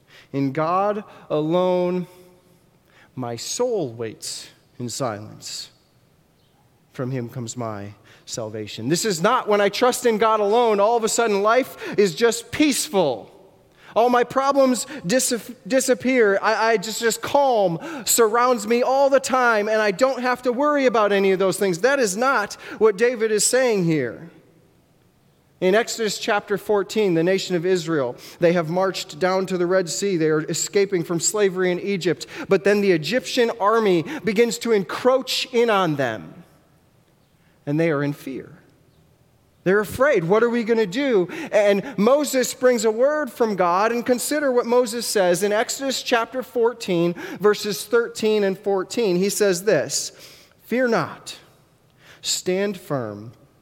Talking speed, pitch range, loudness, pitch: 155 wpm, 175-235 Hz, -21 LUFS, 205 Hz